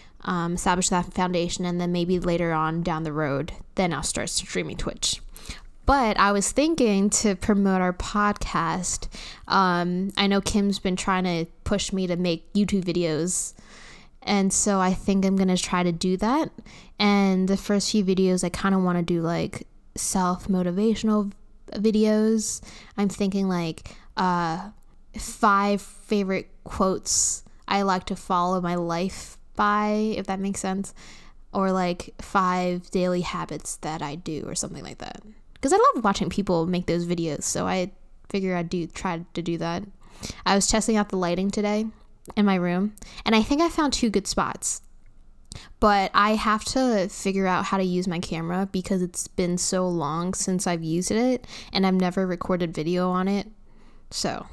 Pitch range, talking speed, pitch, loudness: 180-205 Hz, 175 wpm, 190 Hz, -24 LUFS